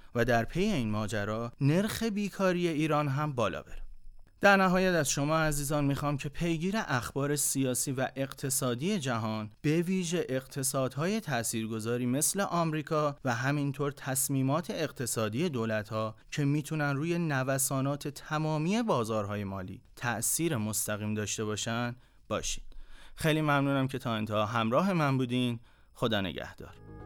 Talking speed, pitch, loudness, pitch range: 125 wpm, 135 Hz, -30 LUFS, 115-155 Hz